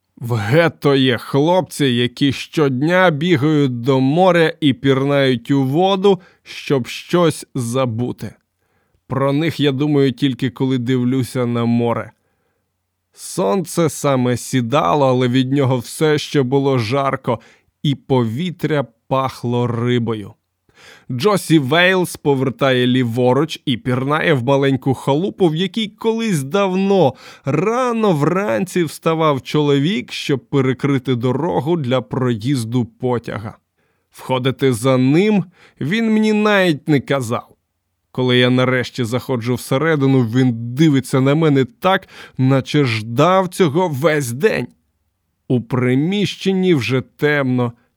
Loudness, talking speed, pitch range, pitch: -17 LUFS, 110 wpm, 125-160 Hz, 135 Hz